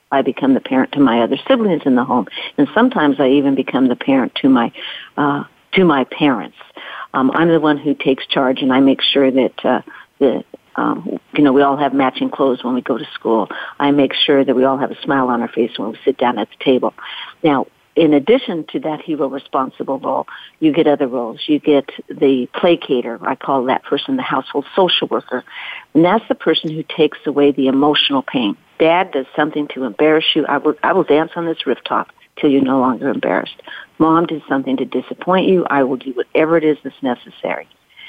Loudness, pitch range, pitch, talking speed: -16 LUFS, 135-165 Hz, 145 Hz, 215 wpm